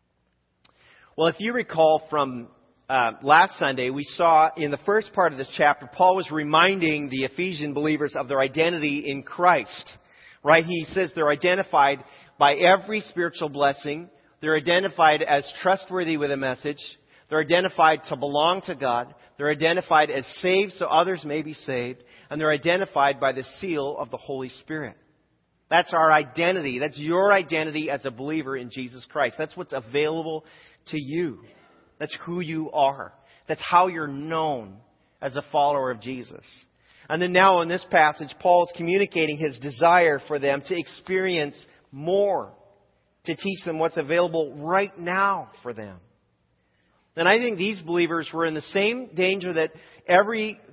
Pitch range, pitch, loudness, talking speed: 140-175 Hz, 155 Hz, -23 LUFS, 160 wpm